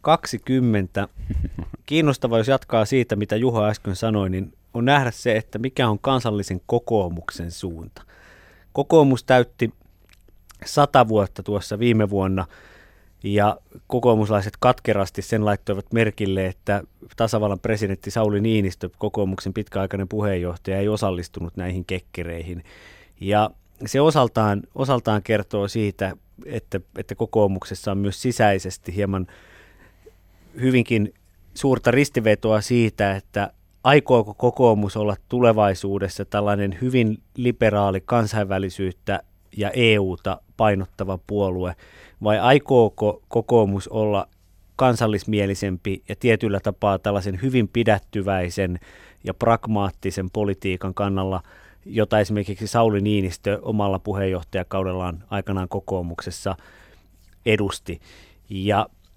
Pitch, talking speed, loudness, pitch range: 100 Hz, 100 wpm, -22 LUFS, 95-110 Hz